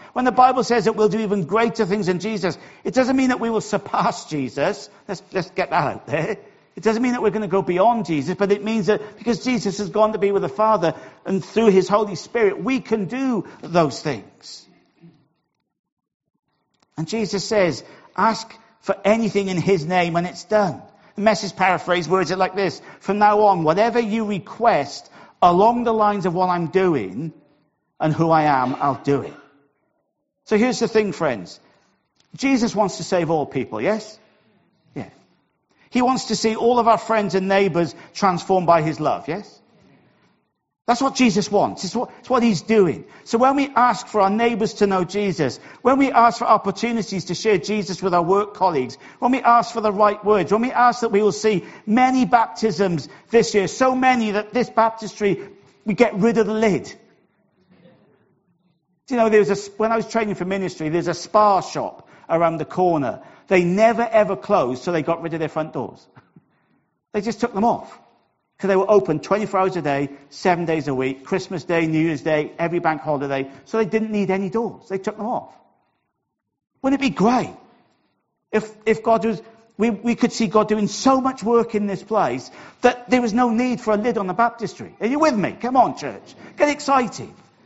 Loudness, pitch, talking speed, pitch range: -20 LUFS, 205 Hz, 200 wpm, 180-225 Hz